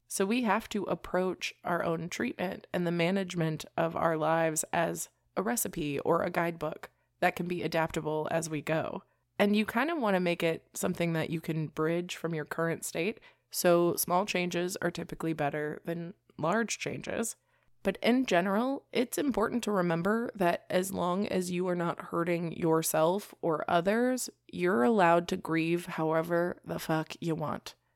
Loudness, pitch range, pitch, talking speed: -31 LUFS, 165-190 Hz, 170 Hz, 170 wpm